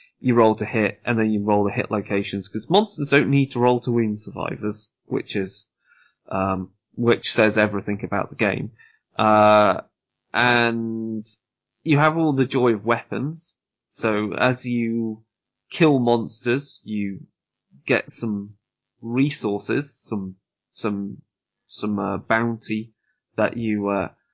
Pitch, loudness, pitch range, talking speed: 110 Hz, -22 LUFS, 105-125 Hz, 135 wpm